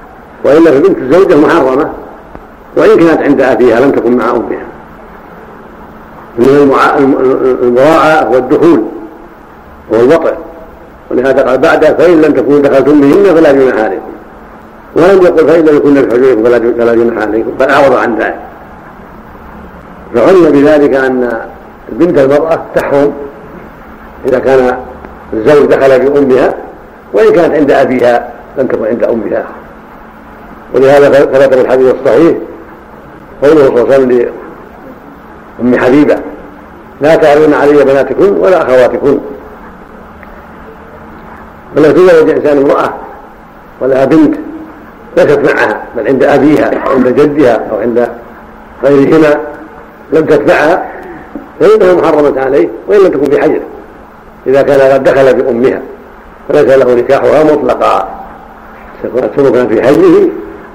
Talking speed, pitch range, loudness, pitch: 115 wpm, 130-160 Hz, -7 LUFS, 140 Hz